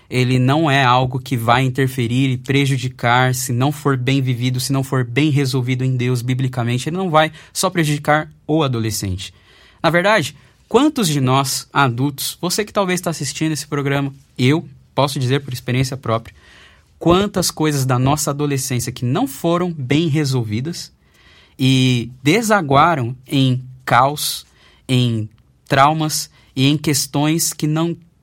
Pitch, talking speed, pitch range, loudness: 135 Hz, 145 wpm, 125-155 Hz, -17 LUFS